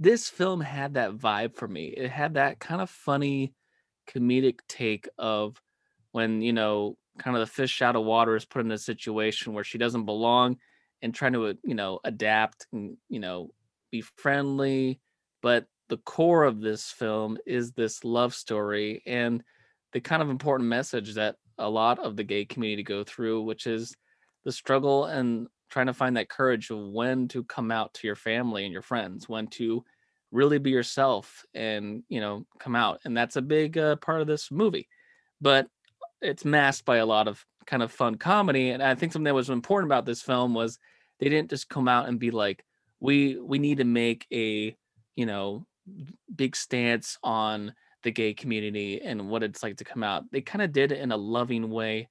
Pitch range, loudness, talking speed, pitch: 110-135 Hz, -28 LUFS, 195 wpm, 120 Hz